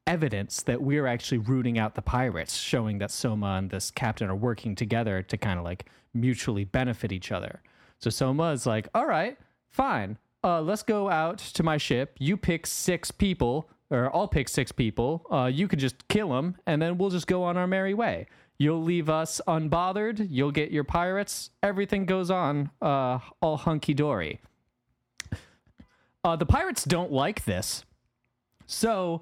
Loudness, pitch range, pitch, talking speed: -28 LUFS, 120-175 Hz, 145 Hz, 175 wpm